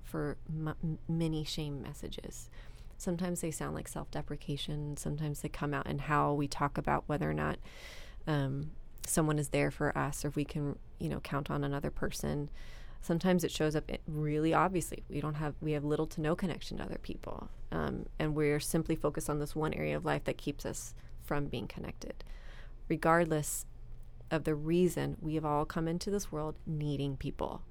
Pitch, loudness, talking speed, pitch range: 150 Hz, -35 LUFS, 185 wpm, 140-160 Hz